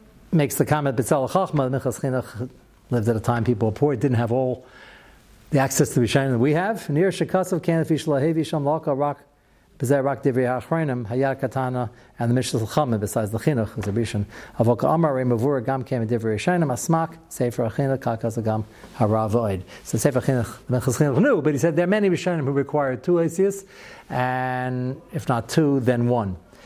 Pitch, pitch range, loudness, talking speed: 130 Hz, 120-155 Hz, -23 LUFS, 175 wpm